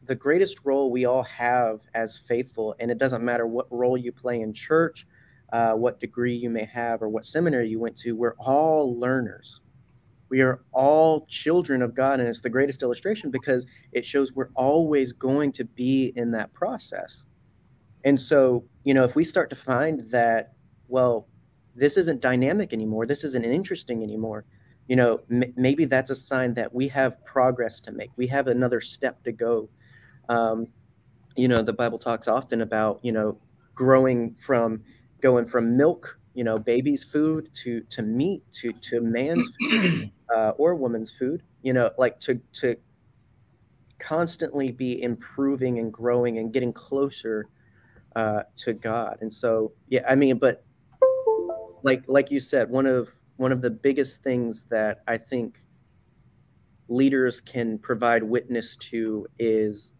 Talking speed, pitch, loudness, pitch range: 165 wpm, 125 Hz, -24 LUFS, 115-135 Hz